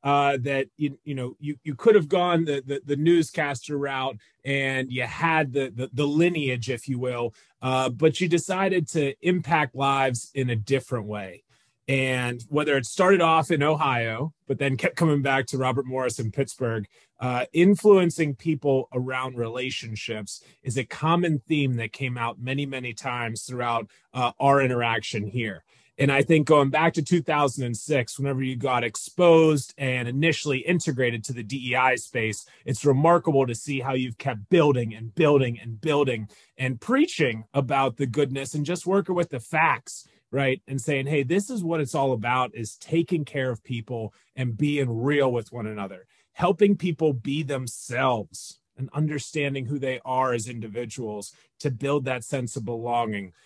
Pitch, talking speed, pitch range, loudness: 135 Hz, 170 wpm, 125-150 Hz, -25 LUFS